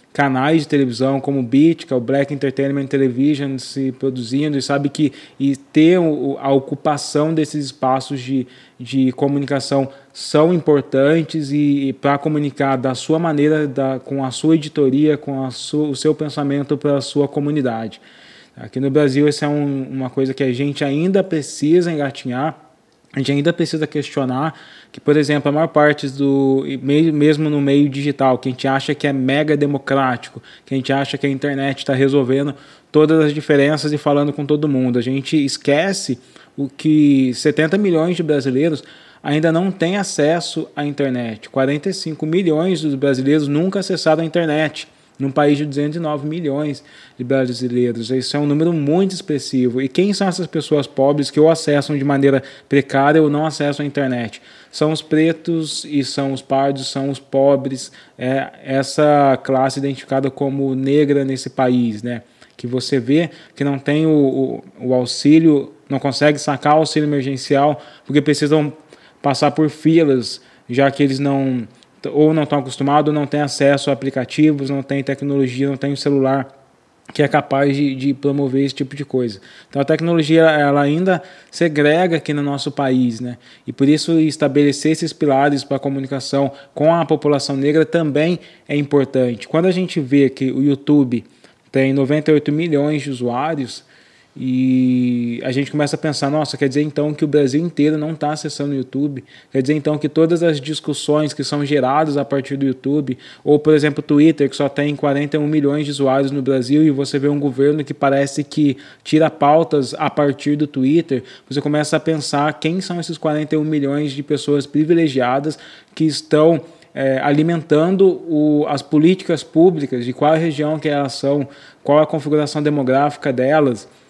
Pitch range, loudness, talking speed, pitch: 135-155 Hz, -17 LUFS, 175 wpm, 145 Hz